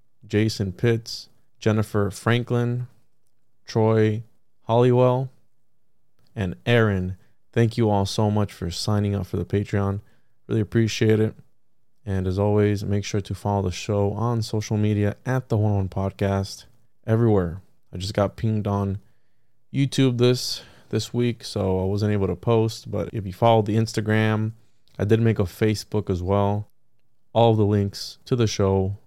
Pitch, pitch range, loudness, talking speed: 110 Hz, 100-115 Hz, -23 LUFS, 150 wpm